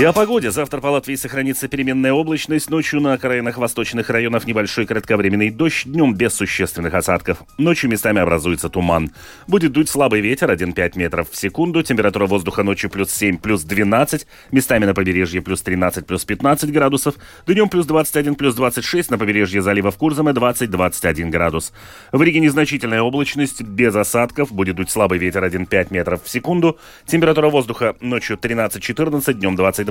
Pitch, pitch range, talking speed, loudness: 115 Hz, 95-145 Hz, 165 wpm, -17 LUFS